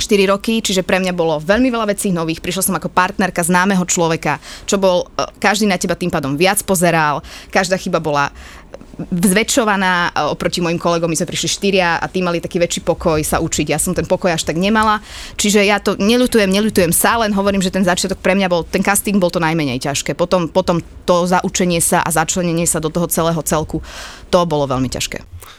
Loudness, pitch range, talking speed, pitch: -16 LUFS, 165-195 Hz, 205 wpm, 180 Hz